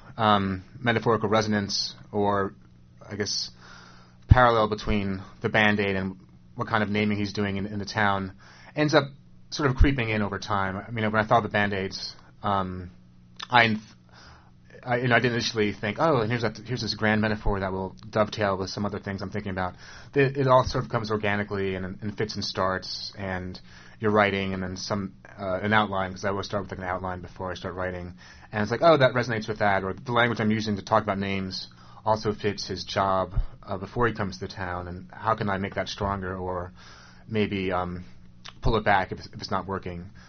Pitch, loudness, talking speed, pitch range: 100 Hz, -26 LUFS, 210 wpm, 90-110 Hz